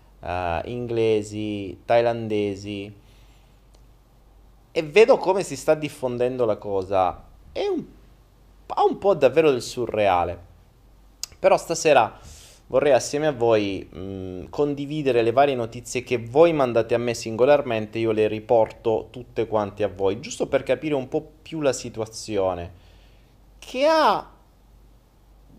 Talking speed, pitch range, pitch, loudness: 125 wpm, 105-145 Hz, 120 Hz, -23 LUFS